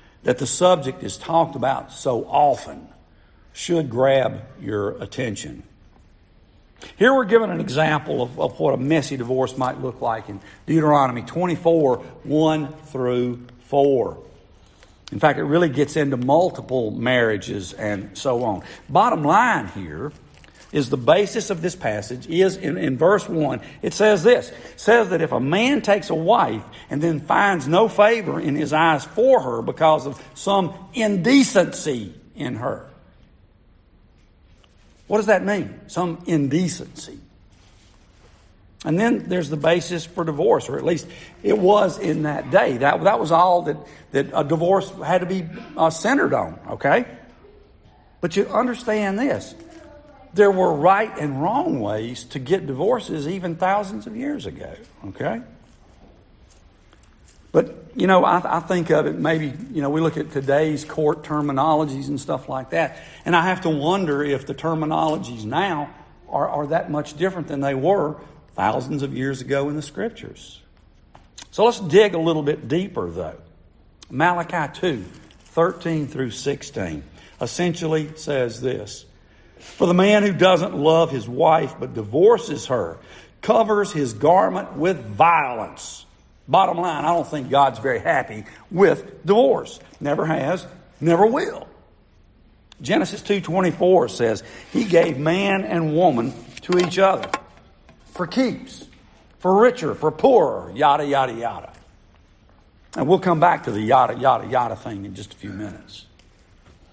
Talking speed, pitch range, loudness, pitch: 150 wpm, 125-180 Hz, -20 LUFS, 155 Hz